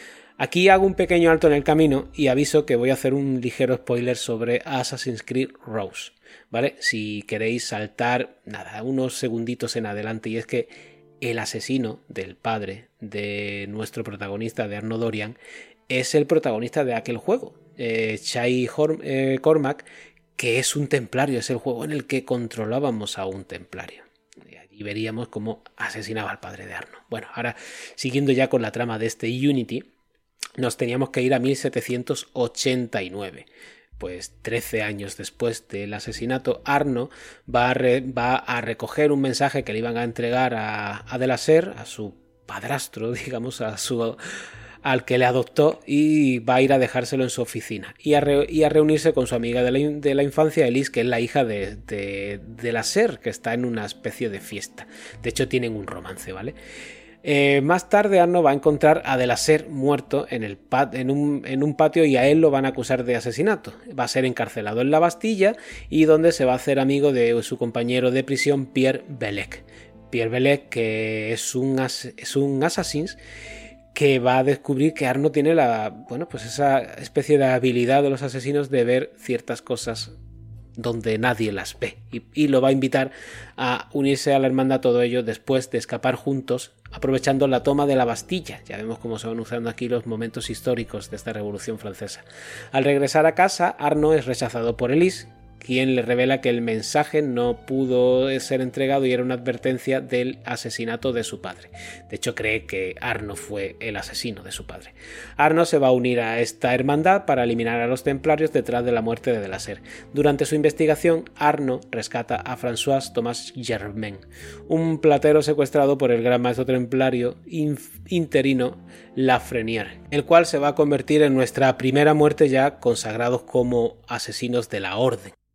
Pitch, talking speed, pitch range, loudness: 125 Hz, 185 wpm, 115-140 Hz, -22 LUFS